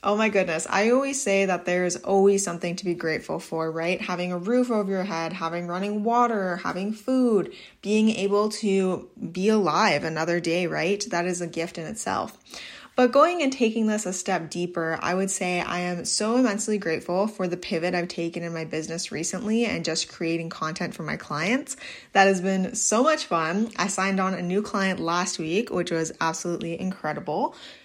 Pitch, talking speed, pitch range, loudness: 185 Hz, 195 wpm, 170-210 Hz, -25 LUFS